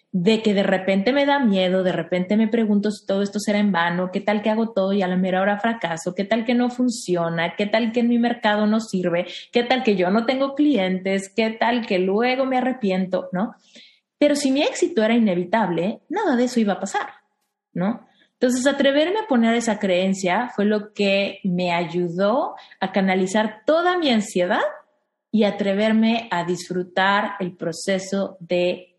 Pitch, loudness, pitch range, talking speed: 210 Hz, -21 LUFS, 185-235 Hz, 190 wpm